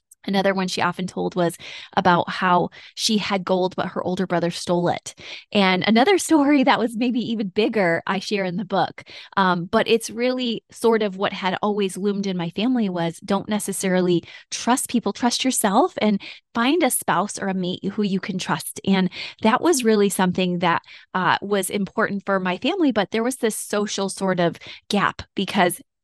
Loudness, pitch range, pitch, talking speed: -21 LUFS, 185-225 Hz, 200 Hz, 190 wpm